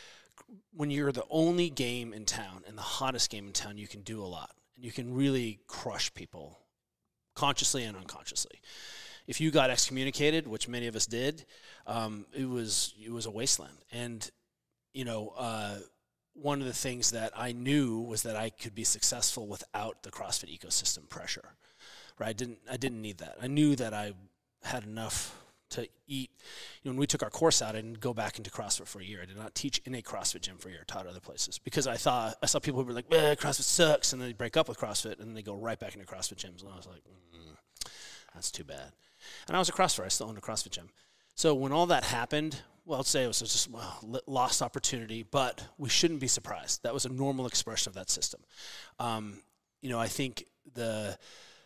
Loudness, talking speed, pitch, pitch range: -32 LUFS, 225 wpm, 120 Hz, 105-135 Hz